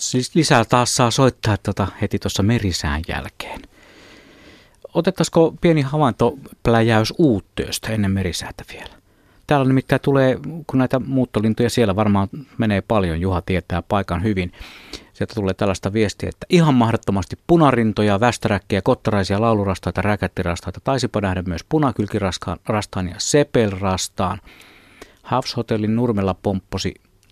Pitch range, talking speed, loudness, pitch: 95-125 Hz, 115 wpm, -19 LUFS, 110 Hz